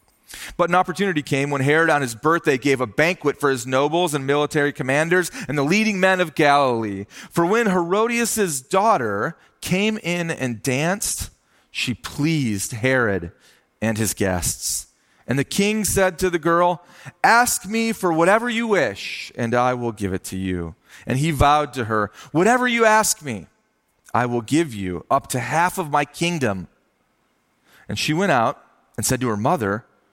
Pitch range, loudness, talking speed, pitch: 125-180 Hz, -20 LUFS, 170 wpm, 150 Hz